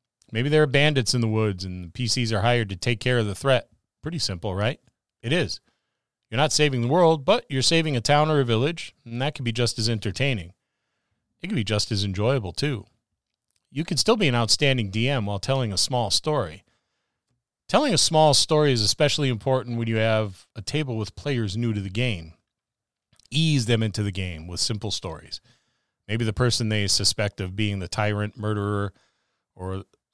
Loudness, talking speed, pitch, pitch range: -23 LUFS, 195 wpm, 115 Hz, 105-130 Hz